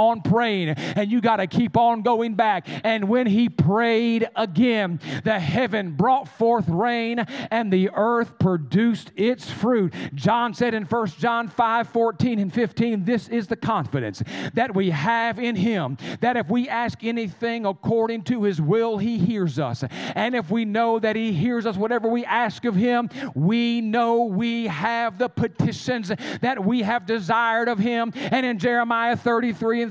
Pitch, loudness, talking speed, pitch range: 230 Hz, -22 LUFS, 175 wpm, 205-235 Hz